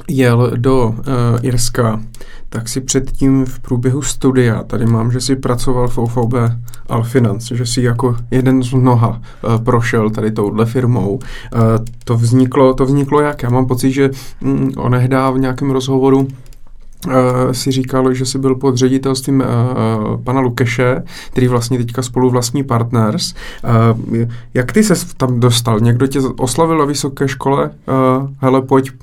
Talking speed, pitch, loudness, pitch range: 160 wpm, 125 Hz, -14 LUFS, 120-135 Hz